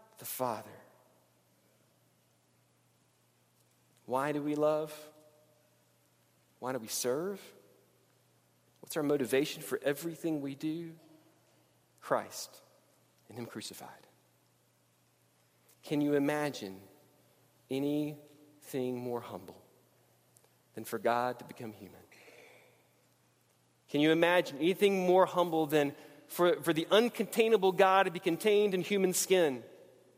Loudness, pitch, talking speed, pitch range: -32 LUFS, 150 Hz, 100 wpm, 120-170 Hz